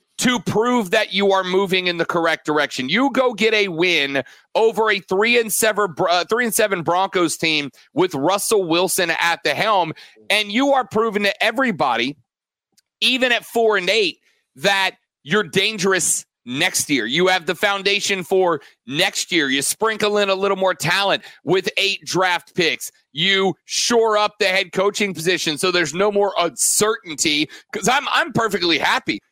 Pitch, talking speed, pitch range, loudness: 200 Hz, 170 wpm, 180-225 Hz, -18 LUFS